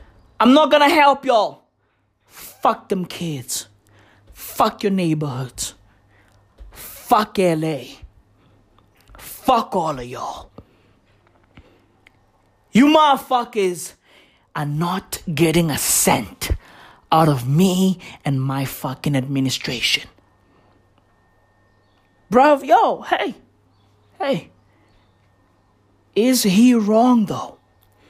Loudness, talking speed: -18 LUFS, 85 wpm